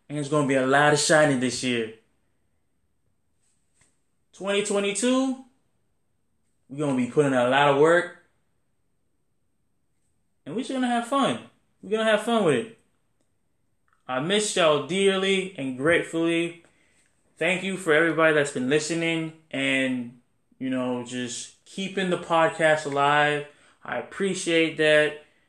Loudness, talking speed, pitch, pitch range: -23 LUFS, 135 wpm, 160 Hz, 140-190 Hz